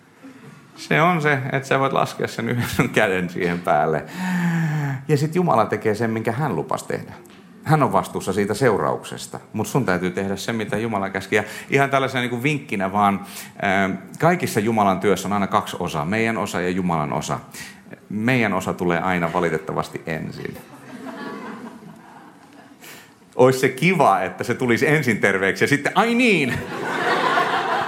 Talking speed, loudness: 155 wpm, -21 LUFS